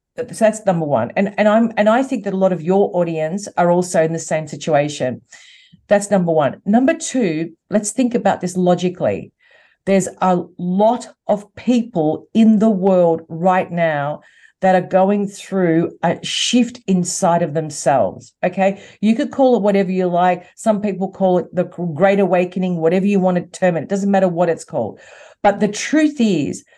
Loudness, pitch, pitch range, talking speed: -17 LUFS, 190 Hz, 175-210 Hz, 185 wpm